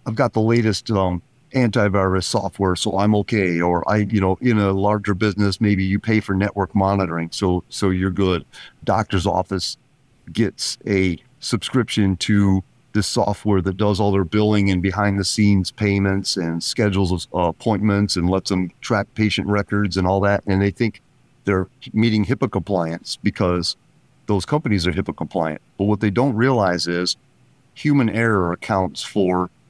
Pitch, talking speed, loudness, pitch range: 100 Hz, 170 wpm, -20 LUFS, 95-110 Hz